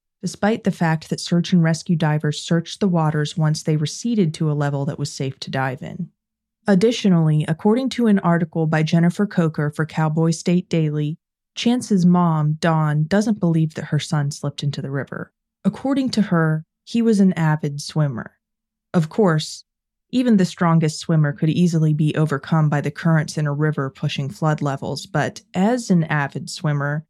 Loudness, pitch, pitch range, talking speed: -20 LUFS, 165 Hz, 150-190 Hz, 175 wpm